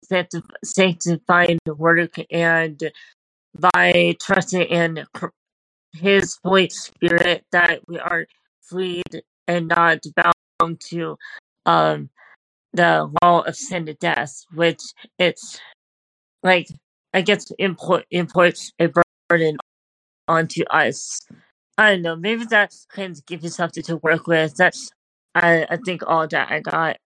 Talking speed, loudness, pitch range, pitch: 125 wpm, -19 LUFS, 160-180 Hz, 170 Hz